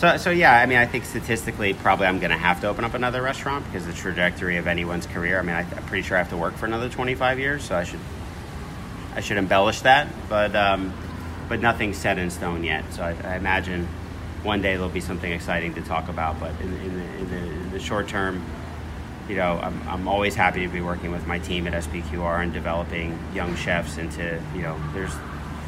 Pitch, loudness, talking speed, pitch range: 90 Hz, -24 LUFS, 225 wpm, 85-100 Hz